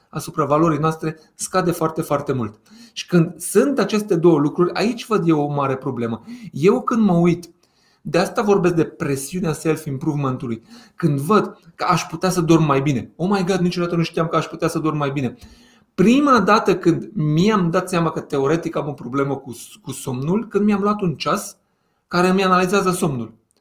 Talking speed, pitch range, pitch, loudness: 190 wpm, 150-190 Hz, 170 Hz, -19 LUFS